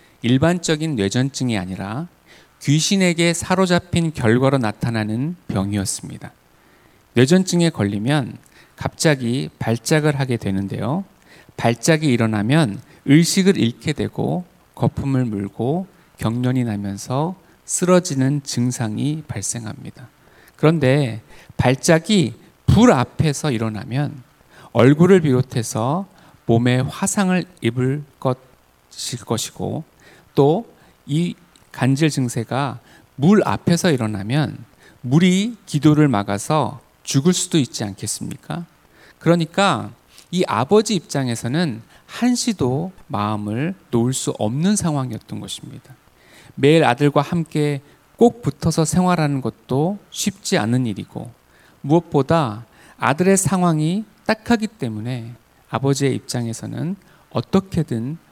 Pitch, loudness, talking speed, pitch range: 140 Hz, -19 LUFS, 250 characters per minute, 120-170 Hz